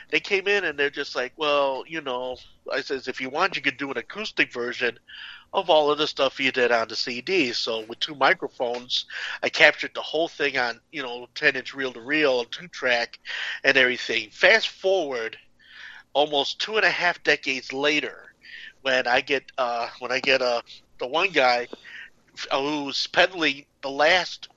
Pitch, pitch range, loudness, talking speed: 140 Hz, 125-155 Hz, -23 LUFS, 175 wpm